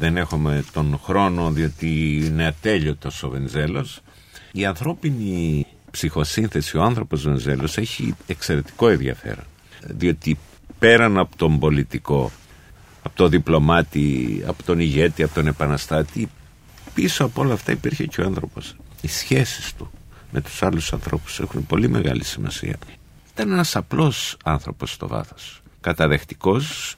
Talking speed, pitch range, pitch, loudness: 130 wpm, 75-95 Hz, 80 Hz, -21 LUFS